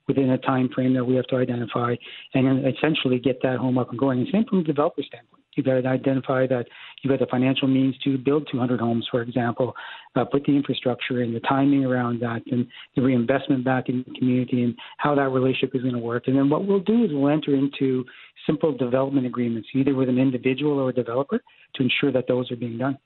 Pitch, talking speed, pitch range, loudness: 130 Hz, 235 wpm, 125-140 Hz, -23 LUFS